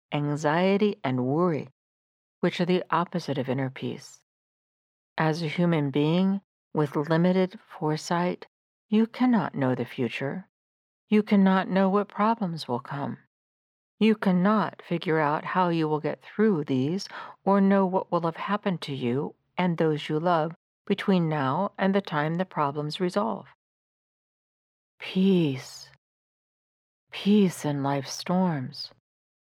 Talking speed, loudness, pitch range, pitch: 130 wpm, -26 LUFS, 145-190 Hz, 170 Hz